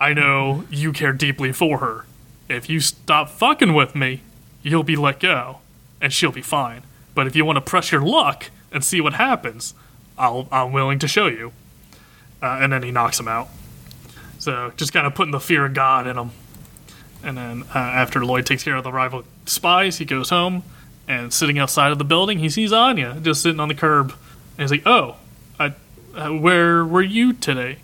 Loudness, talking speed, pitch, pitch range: -18 LUFS, 205 wpm, 145 Hz, 130-160 Hz